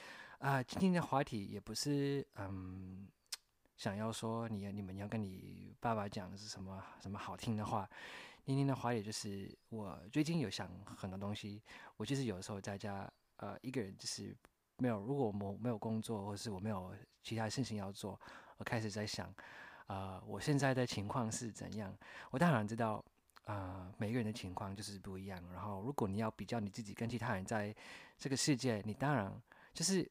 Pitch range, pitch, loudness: 100-120 Hz, 110 Hz, -41 LUFS